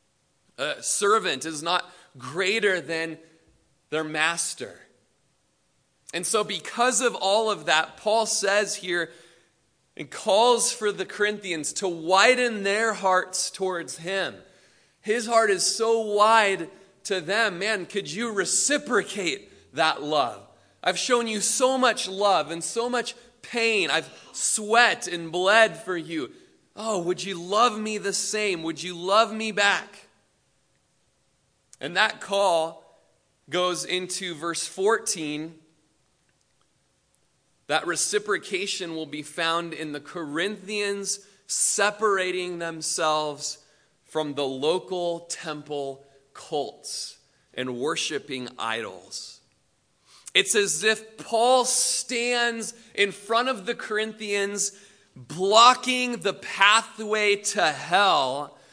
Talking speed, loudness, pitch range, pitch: 110 wpm, -24 LUFS, 170-220 Hz, 195 Hz